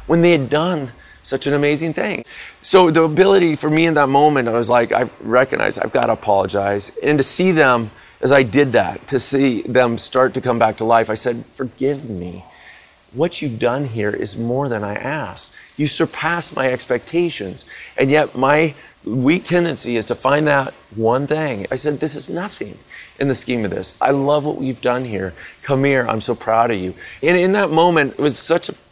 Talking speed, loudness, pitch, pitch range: 210 wpm, -17 LUFS, 135 Hz, 115-150 Hz